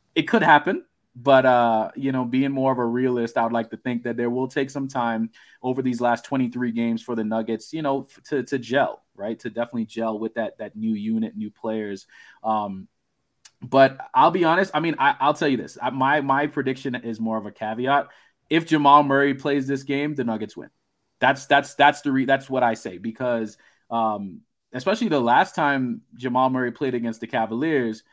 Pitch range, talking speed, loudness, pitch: 115-140 Hz, 205 wpm, -23 LUFS, 125 Hz